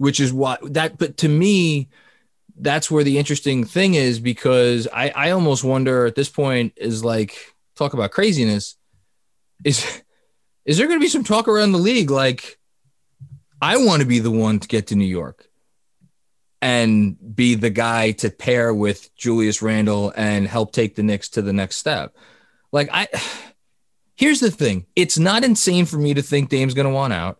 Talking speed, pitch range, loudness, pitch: 175 wpm, 110-150 Hz, -18 LUFS, 130 Hz